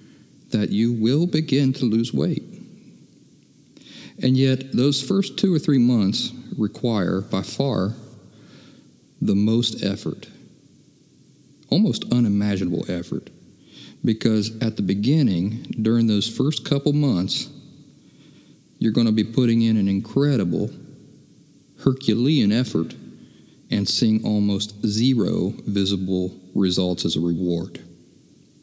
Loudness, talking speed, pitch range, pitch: -22 LUFS, 110 wpm, 100-130 Hz, 110 Hz